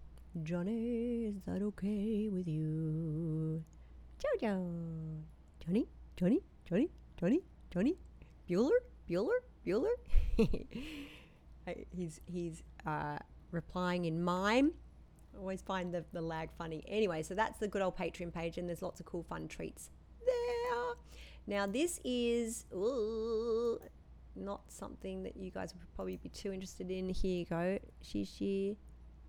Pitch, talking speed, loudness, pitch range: 180 Hz, 130 wpm, -38 LUFS, 160-220 Hz